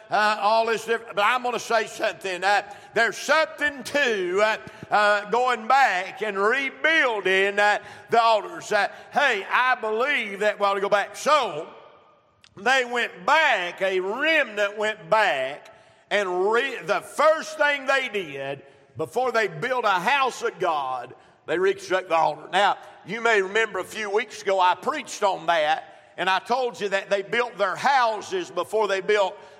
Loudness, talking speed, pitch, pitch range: -23 LUFS, 170 wpm, 215 Hz, 195-250 Hz